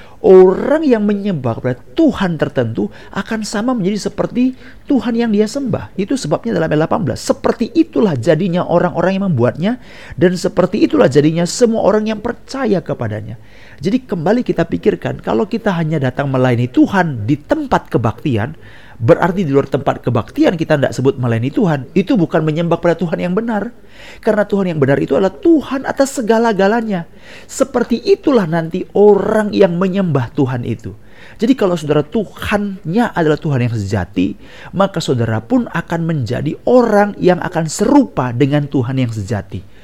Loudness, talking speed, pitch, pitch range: -15 LUFS, 155 wpm, 175 Hz, 140-220 Hz